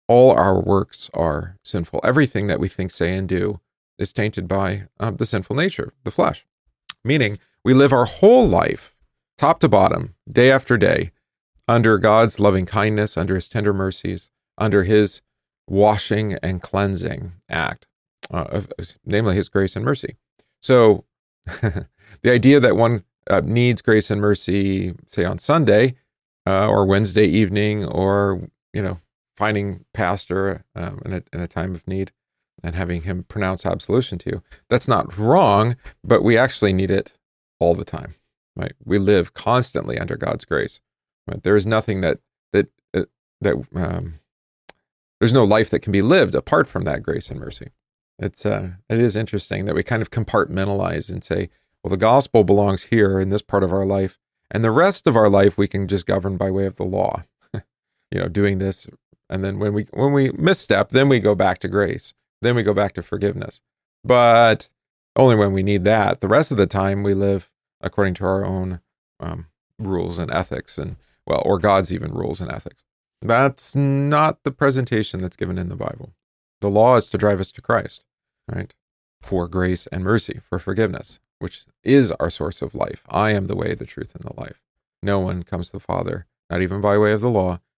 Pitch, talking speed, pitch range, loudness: 100 Hz, 185 wpm, 95-110 Hz, -19 LUFS